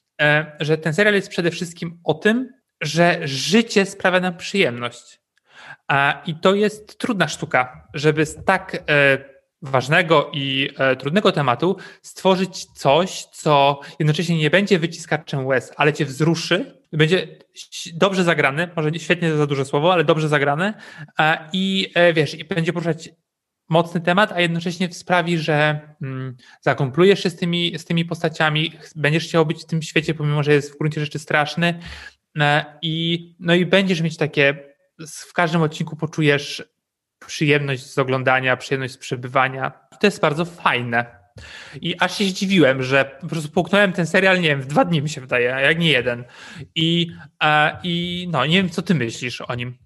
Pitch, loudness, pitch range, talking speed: 160 Hz, -19 LUFS, 145-175 Hz, 160 wpm